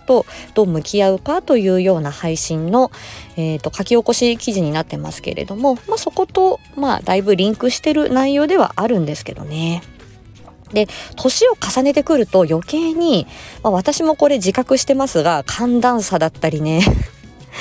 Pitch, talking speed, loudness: 230 Hz, 330 characters per minute, -17 LUFS